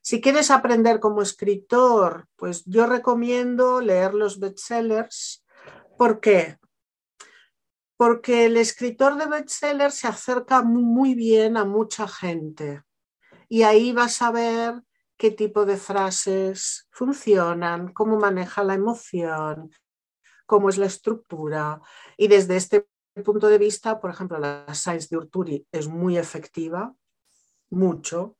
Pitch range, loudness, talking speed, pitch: 180-235 Hz, -22 LUFS, 125 wpm, 210 Hz